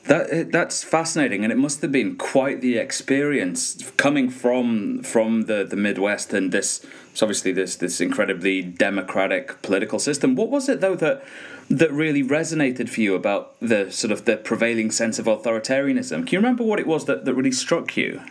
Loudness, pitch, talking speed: -22 LUFS, 135 Hz, 185 wpm